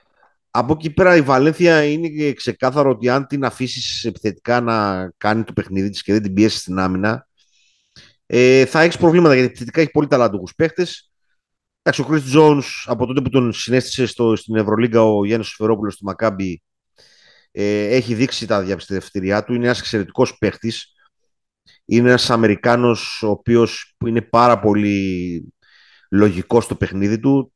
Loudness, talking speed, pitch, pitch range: -17 LUFS, 150 wpm, 120 Hz, 105-135 Hz